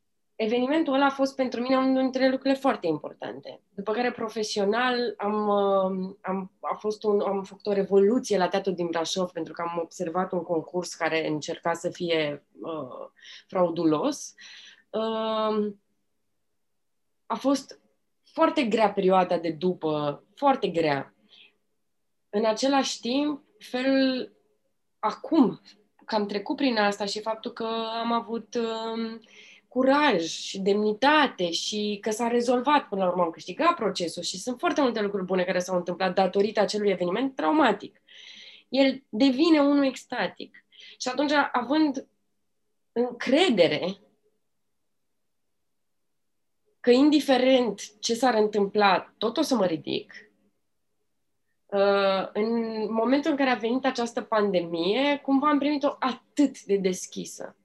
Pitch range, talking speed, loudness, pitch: 190-265 Hz, 130 wpm, -26 LUFS, 215 Hz